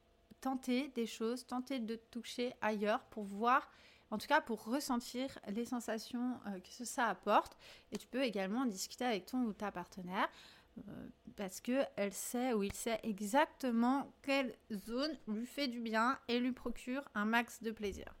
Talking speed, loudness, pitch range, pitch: 170 wpm, -39 LUFS, 215-255 Hz, 235 Hz